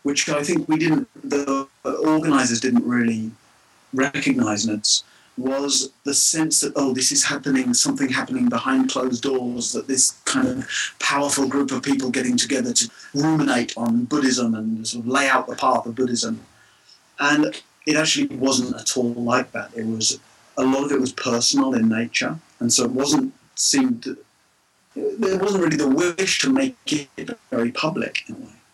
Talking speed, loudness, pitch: 170 wpm, -21 LUFS, 140 Hz